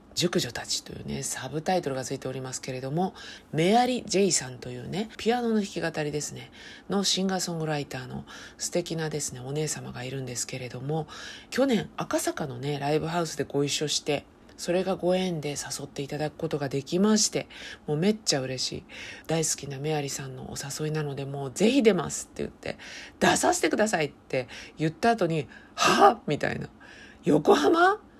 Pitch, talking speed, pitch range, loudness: 155 Hz, 385 characters per minute, 140-185 Hz, -27 LUFS